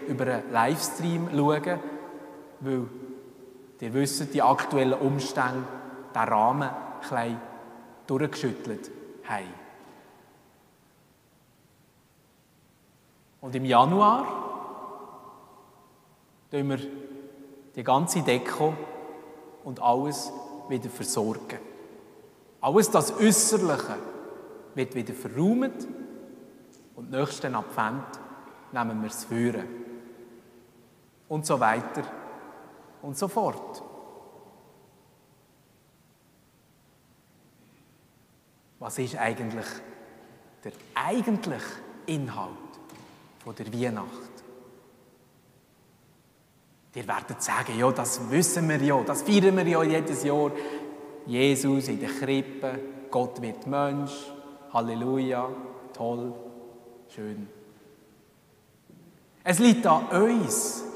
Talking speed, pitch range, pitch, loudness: 80 wpm, 125-155 Hz, 135 Hz, -27 LUFS